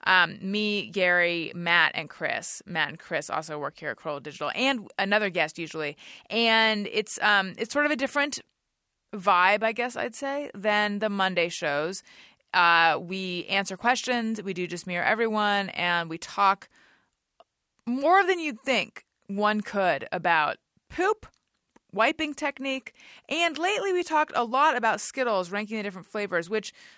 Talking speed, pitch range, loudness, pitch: 160 wpm, 185-255 Hz, -26 LUFS, 210 Hz